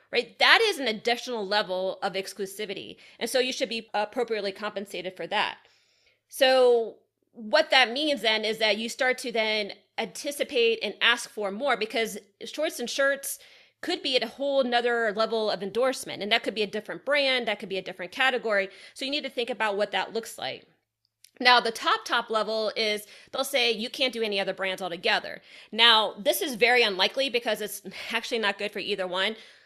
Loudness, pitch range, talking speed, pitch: -26 LUFS, 205-255 Hz, 195 wpm, 225 Hz